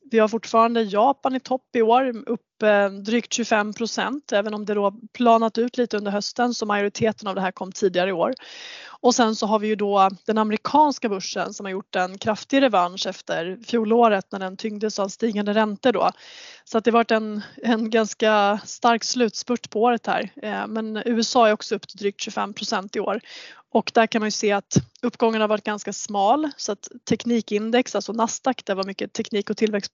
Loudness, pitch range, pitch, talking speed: -22 LUFS, 205-235 Hz, 220 Hz, 200 wpm